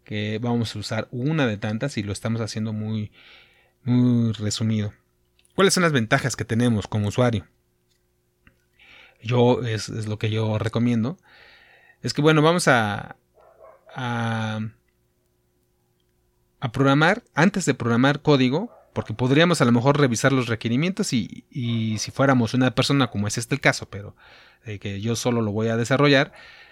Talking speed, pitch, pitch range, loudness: 155 wpm, 115 Hz, 105-135 Hz, -22 LUFS